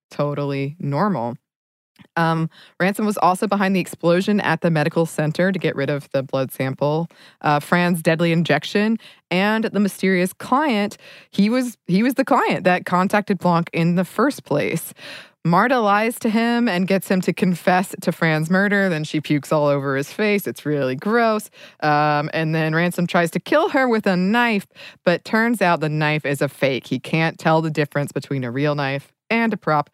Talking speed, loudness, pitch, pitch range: 190 wpm, -20 LUFS, 175 Hz, 150-205 Hz